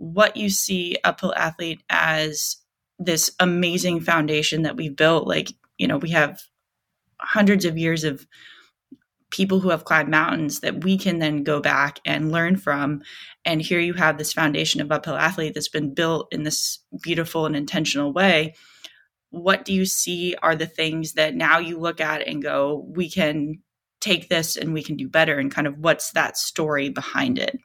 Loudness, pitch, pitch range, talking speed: -21 LUFS, 160 Hz, 150-175 Hz, 180 wpm